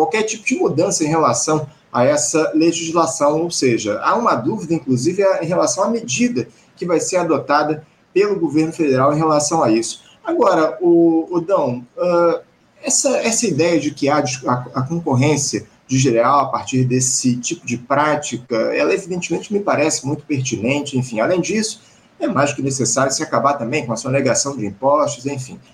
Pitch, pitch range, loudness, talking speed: 150 Hz, 130-170 Hz, -17 LUFS, 175 wpm